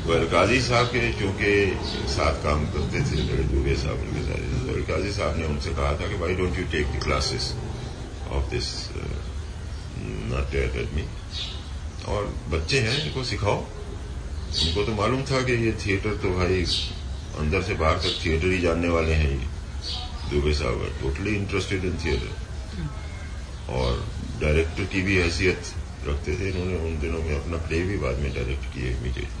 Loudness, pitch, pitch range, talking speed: -26 LUFS, 80 Hz, 75-95 Hz, 155 wpm